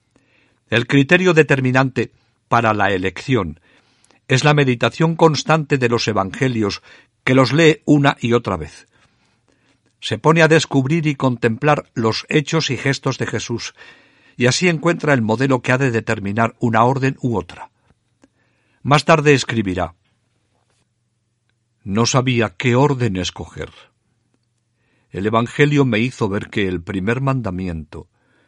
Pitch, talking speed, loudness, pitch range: 120 Hz, 130 wpm, -17 LUFS, 115-135 Hz